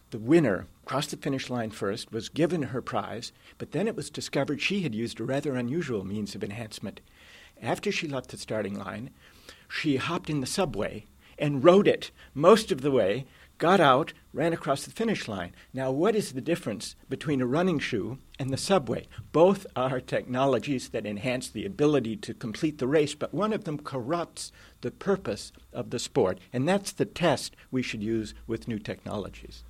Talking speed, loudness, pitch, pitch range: 190 wpm, -28 LUFS, 135 Hz, 115-160 Hz